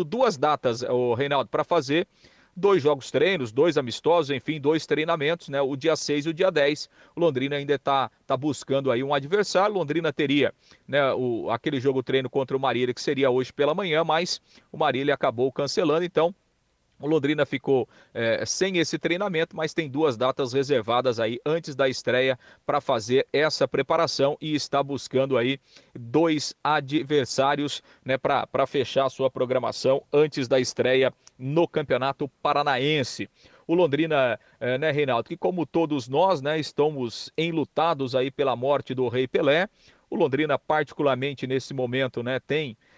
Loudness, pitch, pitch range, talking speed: -25 LUFS, 145 Hz, 130-155 Hz, 160 wpm